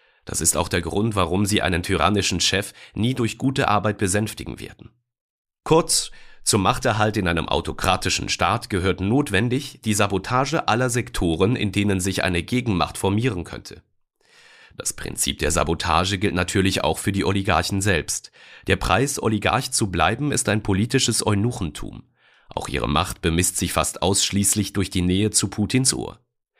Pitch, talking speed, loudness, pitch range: 100 Hz, 155 wpm, -21 LUFS, 90-110 Hz